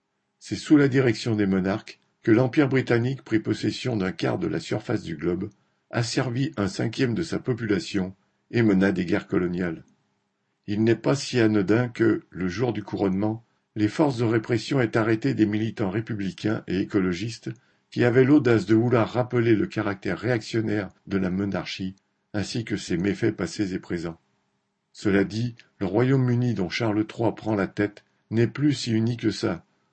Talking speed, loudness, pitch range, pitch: 170 wpm, -25 LUFS, 100-120 Hz, 110 Hz